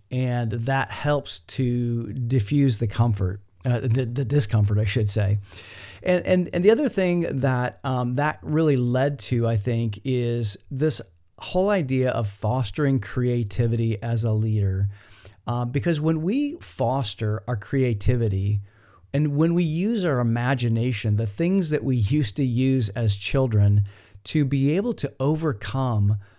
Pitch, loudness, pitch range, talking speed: 125 Hz, -24 LUFS, 105-140 Hz, 150 wpm